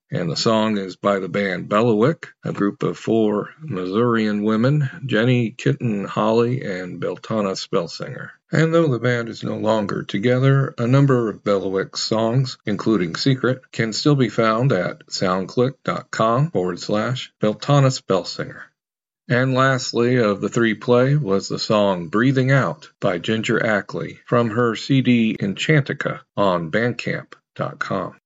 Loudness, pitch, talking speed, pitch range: -20 LUFS, 120 Hz, 135 wpm, 105-135 Hz